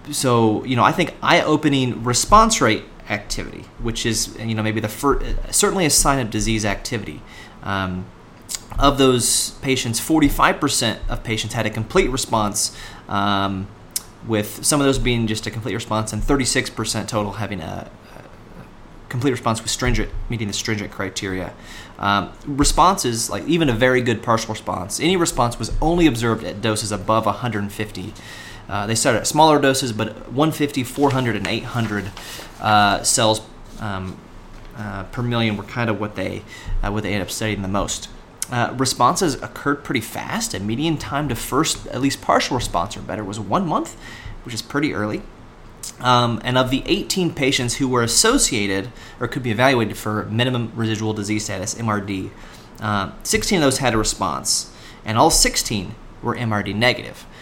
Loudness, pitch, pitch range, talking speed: -20 LUFS, 110 Hz, 105-125 Hz, 165 wpm